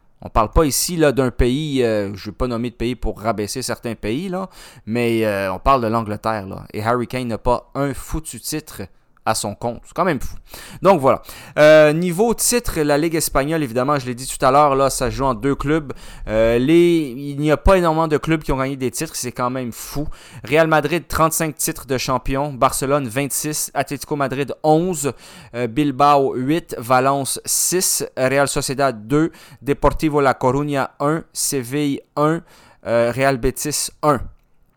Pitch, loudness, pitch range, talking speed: 140 Hz, -19 LUFS, 120-150 Hz, 195 wpm